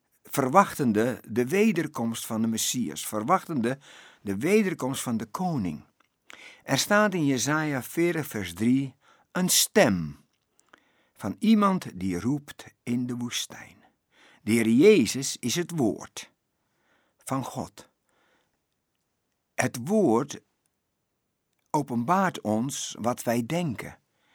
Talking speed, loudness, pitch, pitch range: 105 wpm, -26 LUFS, 130 Hz, 115-160 Hz